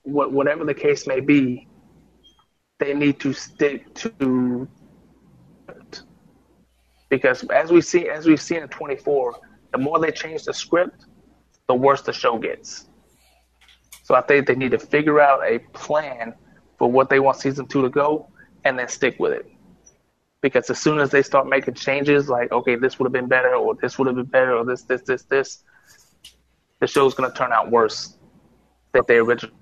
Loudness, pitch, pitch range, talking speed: -20 LUFS, 140 Hz, 130-155 Hz, 180 wpm